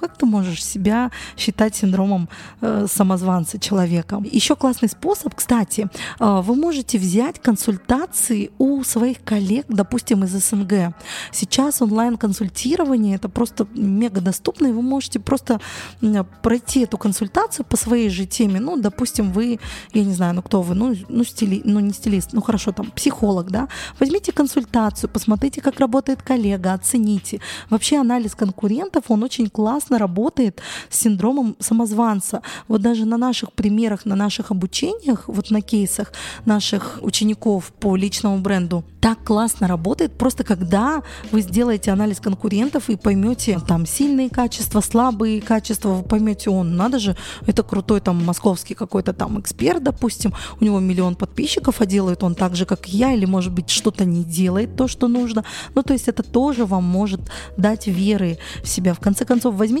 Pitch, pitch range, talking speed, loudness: 220 Hz, 200-245 Hz, 160 wpm, -19 LUFS